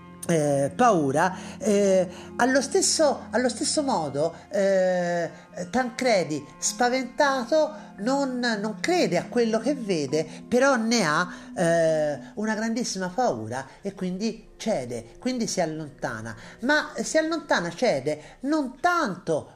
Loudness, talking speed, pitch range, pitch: -25 LUFS, 115 wpm, 175-255 Hz, 215 Hz